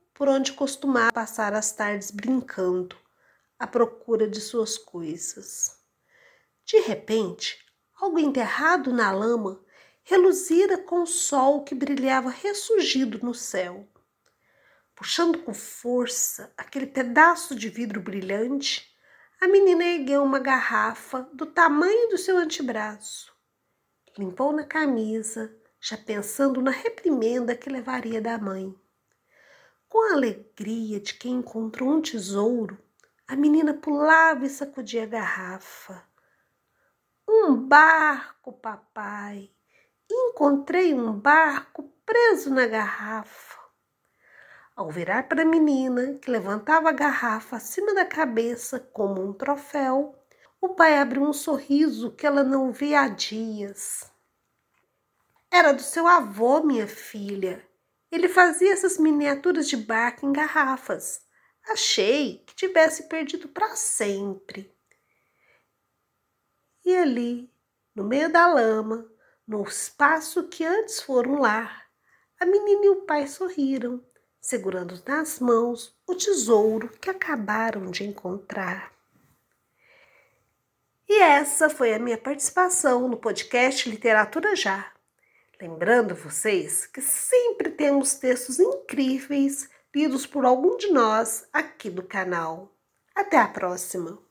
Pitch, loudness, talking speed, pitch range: 270 Hz, -23 LUFS, 115 wpm, 225-320 Hz